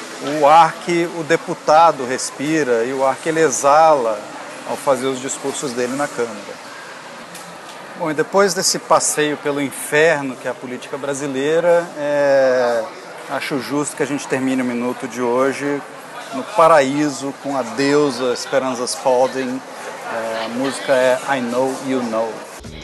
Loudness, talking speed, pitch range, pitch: -18 LUFS, 150 wpm, 130-150 Hz, 140 Hz